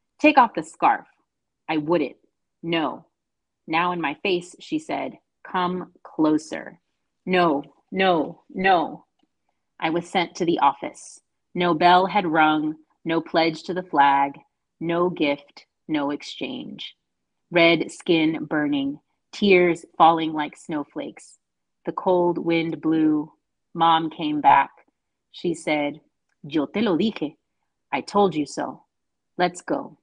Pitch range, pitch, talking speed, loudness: 155-180 Hz, 165 Hz, 125 wpm, -22 LUFS